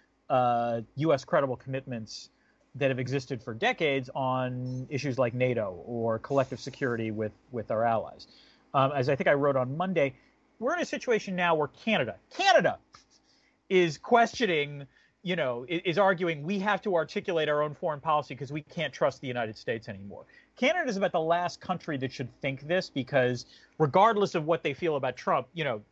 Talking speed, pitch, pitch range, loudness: 185 wpm, 145 Hz, 130-180 Hz, -29 LUFS